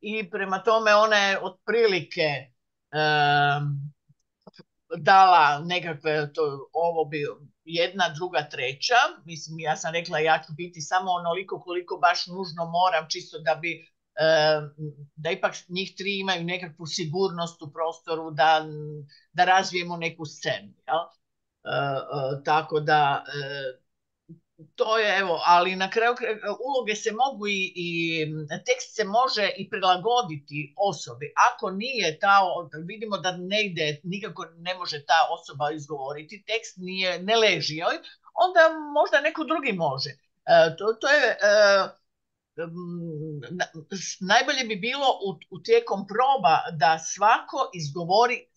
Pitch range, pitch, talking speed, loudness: 155-210 Hz, 175 Hz, 130 wpm, -24 LUFS